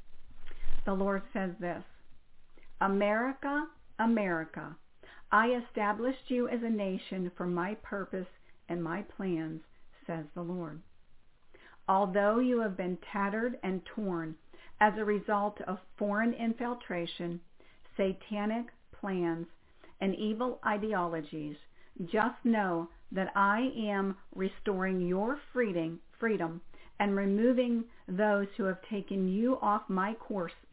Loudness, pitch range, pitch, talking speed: -33 LUFS, 180-220 Hz, 200 Hz, 110 wpm